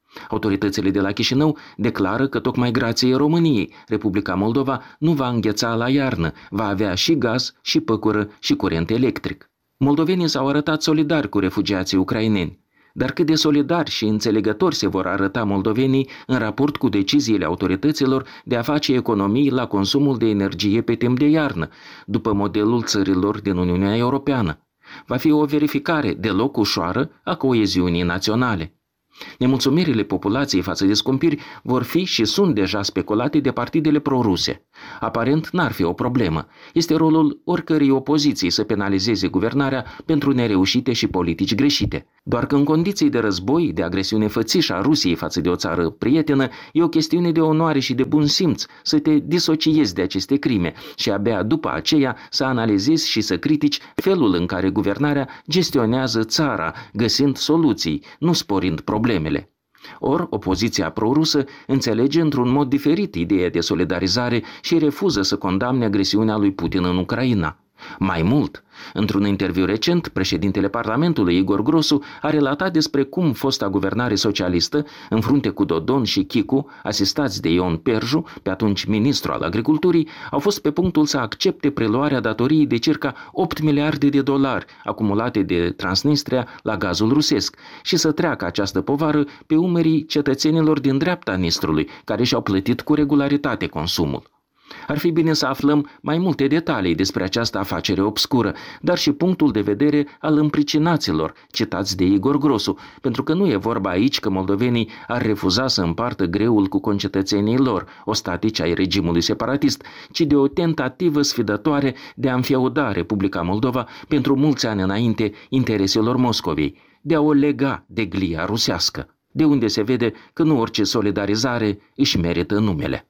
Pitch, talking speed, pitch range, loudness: 125 Hz, 155 wpm, 100-150 Hz, -20 LUFS